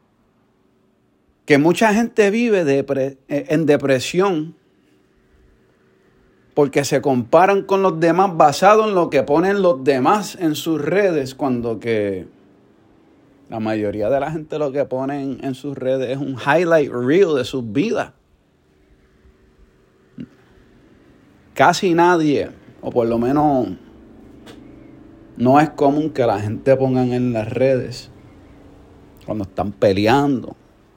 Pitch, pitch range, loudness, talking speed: 135 Hz, 110-160 Hz, -18 LUFS, 120 wpm